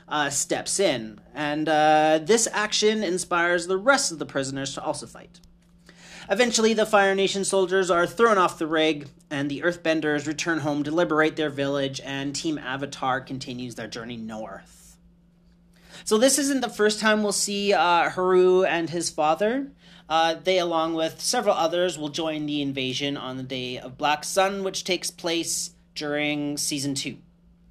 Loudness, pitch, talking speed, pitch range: -24 LUFS, 165 Hz, 165 wpm, 150-185 Hz